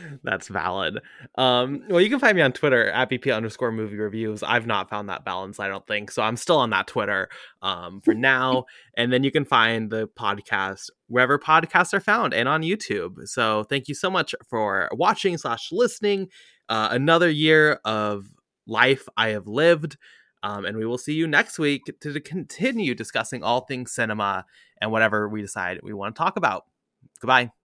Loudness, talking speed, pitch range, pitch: -23 LUFS, 190 wpm, 105-155 Hz, 125 Hz